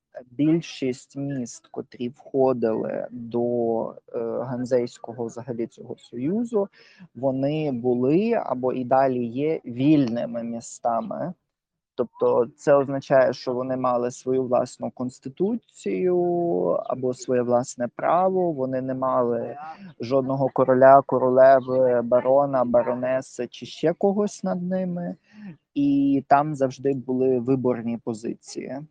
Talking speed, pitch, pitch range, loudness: 100 wpm, 130 Hz, 125-155 Hz, -23 LUFS